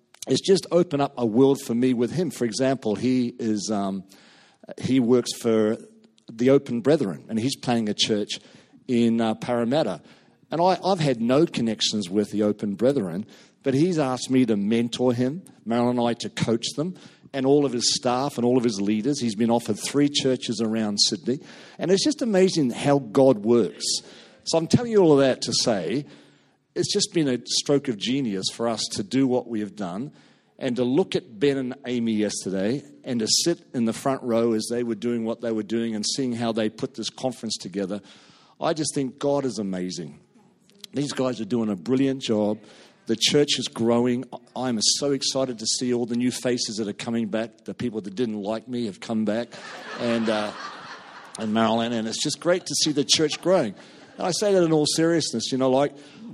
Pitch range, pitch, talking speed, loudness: 115-140 Hz, 120 Hz, 205 wpm, -24 LUFS